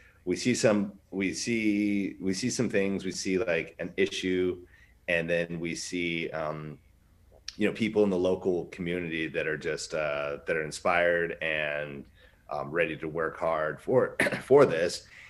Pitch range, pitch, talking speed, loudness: 85-100 Hz, 90 Hz, 165 wpm, -29 LUFS